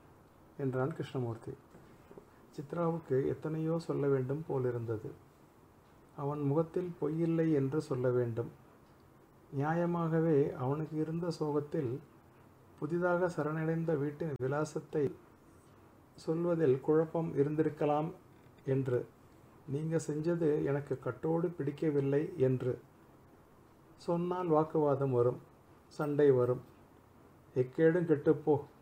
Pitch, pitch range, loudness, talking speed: 150 Hz, 135-160 Hz, -34 LUFS, 80 wpm